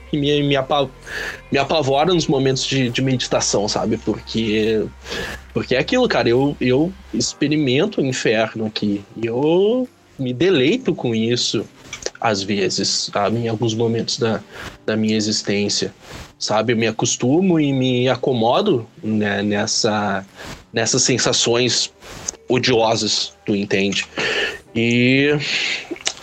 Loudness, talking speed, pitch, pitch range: -19 LUFS, 115 wpm, 120 Hz, 110-140 Hz